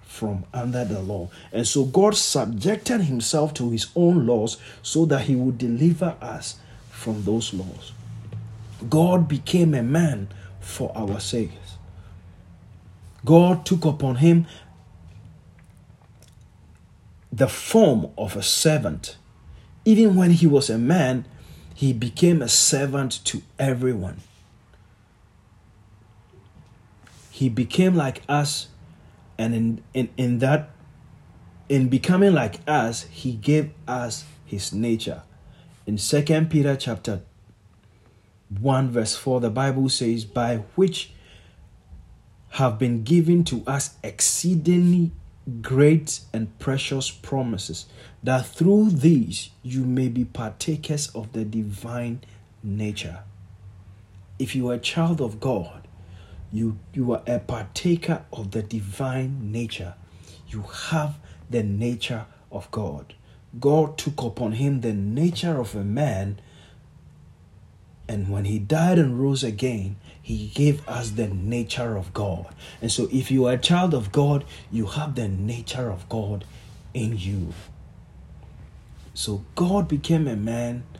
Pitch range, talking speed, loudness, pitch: 100-140 Hz, 125 wpm, -23 LUFS, 115 Hz